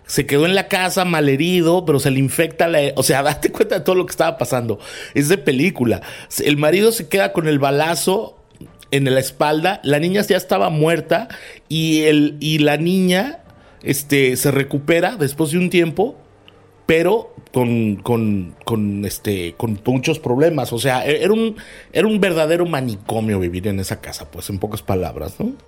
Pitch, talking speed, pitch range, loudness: 150 Hz, 180 wpm, 125-175 Hz, -18 LUFS